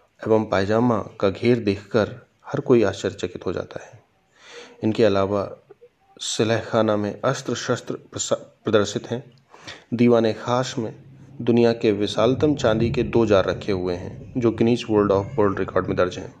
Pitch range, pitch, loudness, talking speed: 105-120 Hz, 115 Hz, -22 LUFS, 150 wpm